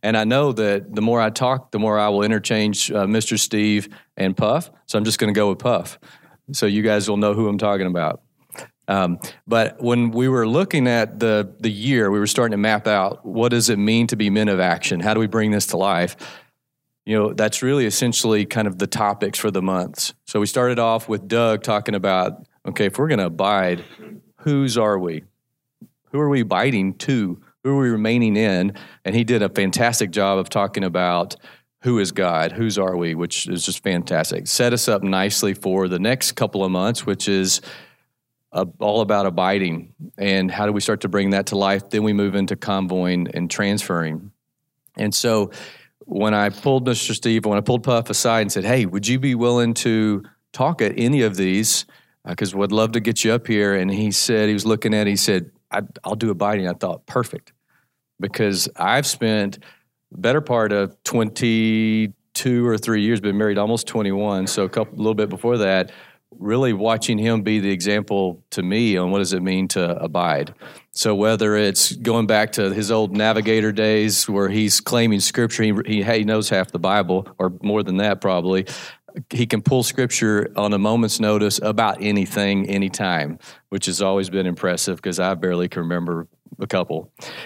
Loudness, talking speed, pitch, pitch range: -20 LUFS, 200 wpm, 105 Hz, 100-115 Hz